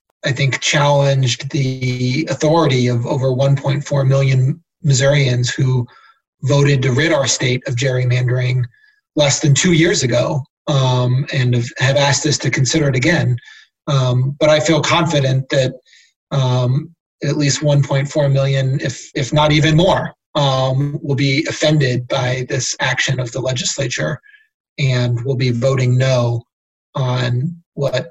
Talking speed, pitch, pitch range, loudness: 140 wpm, 135 Hz, 130-150 Hz, -16 LUFS